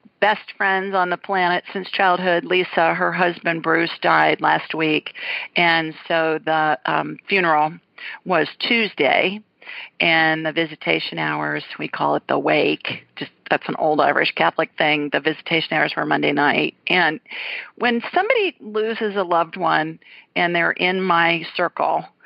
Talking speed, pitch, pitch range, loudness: 145 wpm, 175 Hz, 160-205 Hz, -19 LUFS